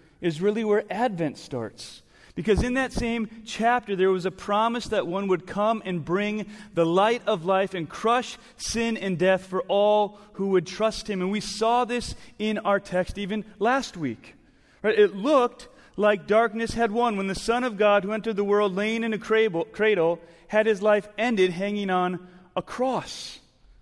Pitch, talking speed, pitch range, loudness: 210 Hz, 185 wpm, 190-230 Hz, -25 LUFS